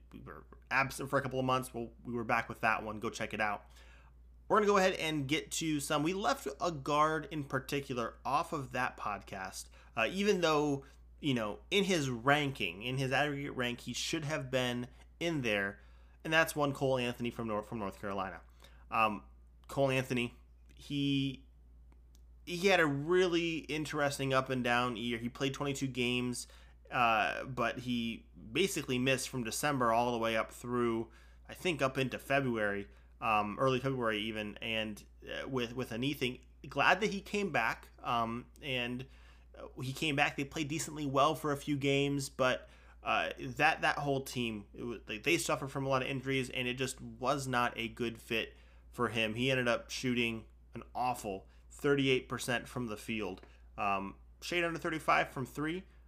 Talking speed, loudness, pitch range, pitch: 180 wpm, -34 LUFS, 110-145 Hz, 125 Hz